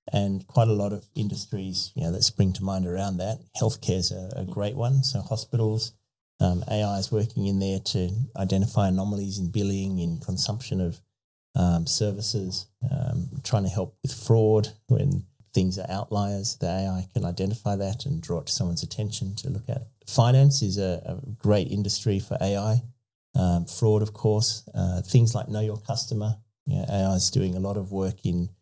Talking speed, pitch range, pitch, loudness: 190 wpm, 95-115 Hz, 105 Hz, -26 LUFS